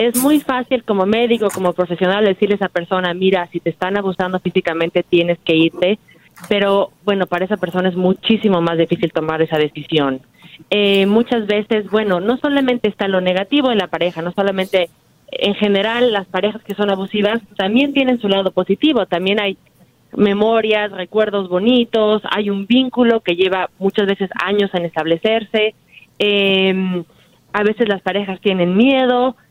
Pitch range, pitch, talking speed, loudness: 180-215 Hz, 200 Hz, 165 wpm, -16 LUFS